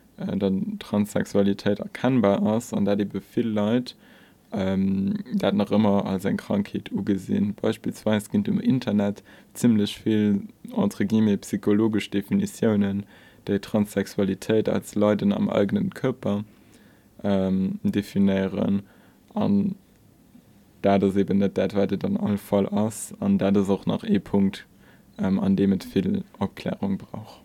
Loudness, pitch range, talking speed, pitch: -24 LUFS, 100-125 Hz, 125 wpm, 105 Hz